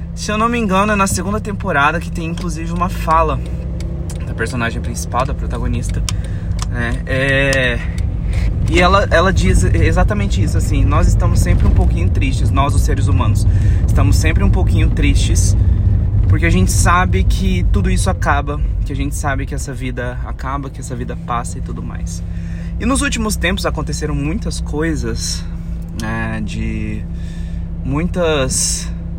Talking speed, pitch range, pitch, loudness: 155 wpm, 85-100 Hz, 95 Hz, -17 LUFS